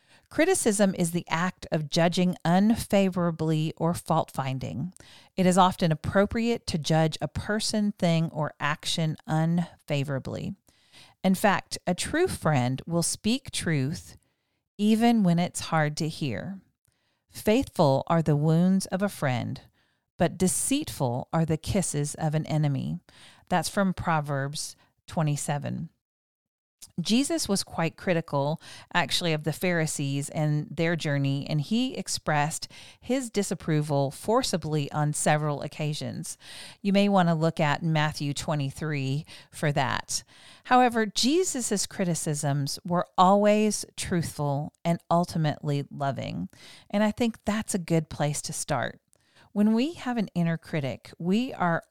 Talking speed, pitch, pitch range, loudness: 130 wpm, 165 Hz, 145-190 Hz, -27 LUFS